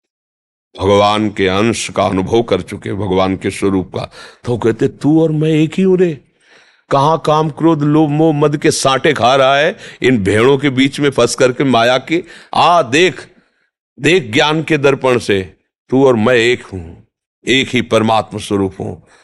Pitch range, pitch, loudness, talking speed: 100-150 Hz, 120 Hz, -13 LUFS, 180 wpm